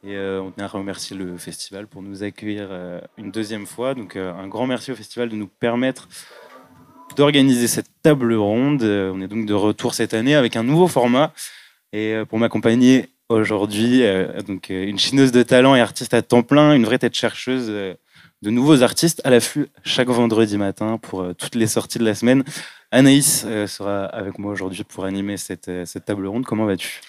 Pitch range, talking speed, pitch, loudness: 100-125 Hz, 185 wpm, 110 Hz, -19 LUFS